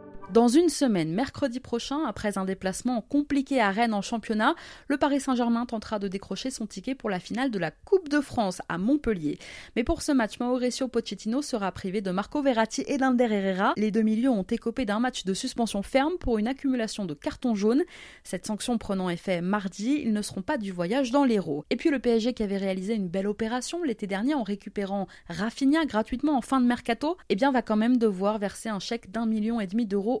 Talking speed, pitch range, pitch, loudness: 215 wpm, 205-265 Hz, 230 Hz, -27 LUFS